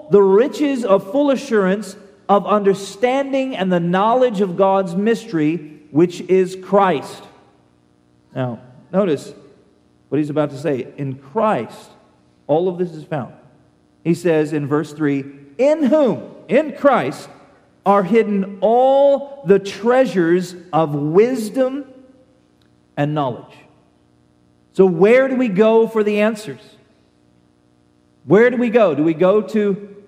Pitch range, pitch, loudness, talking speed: 140-220 Hz, 185 Hz, -17 LUFS, 130 wpm